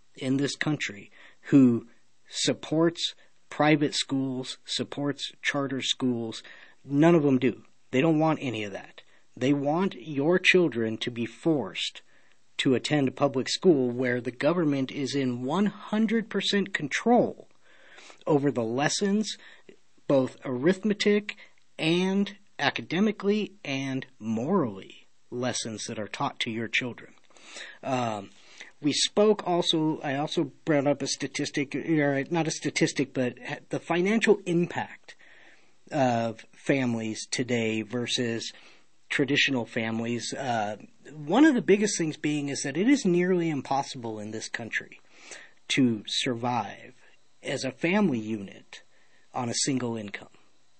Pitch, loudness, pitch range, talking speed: 140 Hz, -27 LUFS, 125-170 Hz, 125 wpm